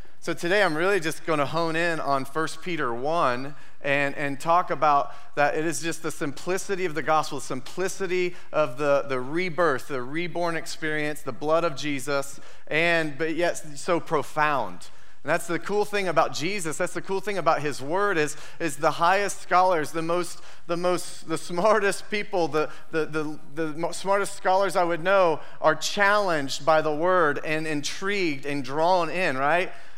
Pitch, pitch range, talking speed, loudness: 165 Hz, 150-180 Hz, 180 wpm, -25 LUFS